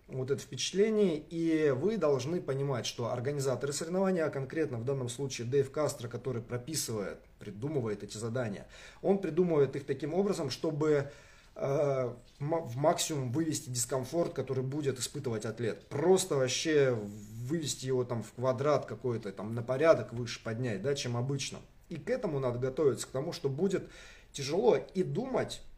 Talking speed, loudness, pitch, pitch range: 155 wpm, -32 LUFS, 140 Hz, 125-155 Hz